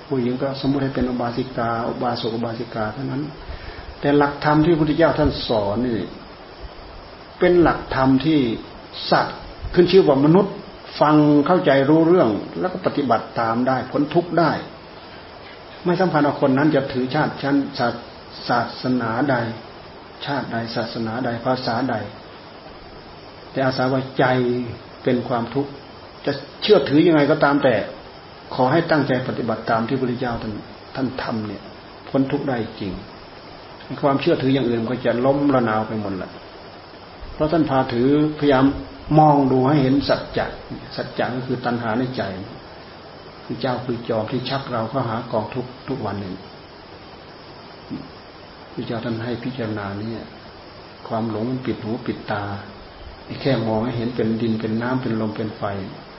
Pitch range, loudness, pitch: 110-140 Hz, -20 LUFS, 125 Hz